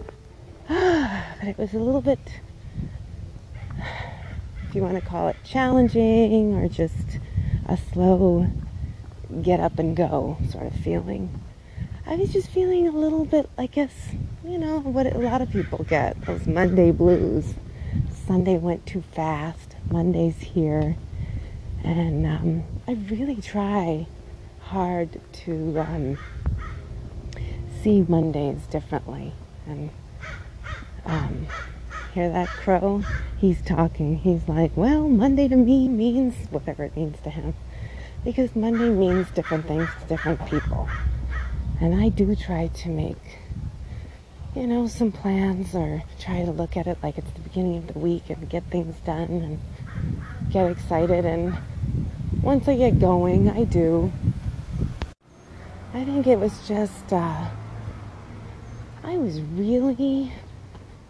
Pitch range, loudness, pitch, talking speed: 155-225 Hz, -24 LUFS, 175 Hz, 130 wpm